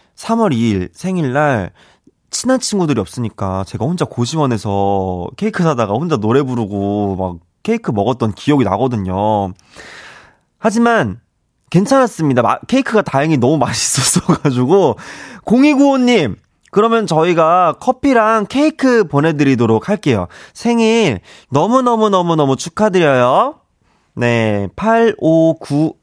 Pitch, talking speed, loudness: 150 Hz, 270 characters per minute, -14 LUFS